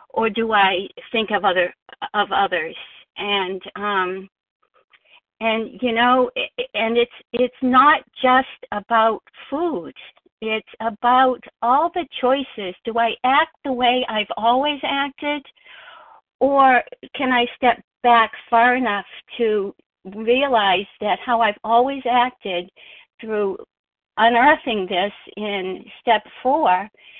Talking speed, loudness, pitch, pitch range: 115 wpm, -19 LUFS, 235 Hz, 210-265 Hz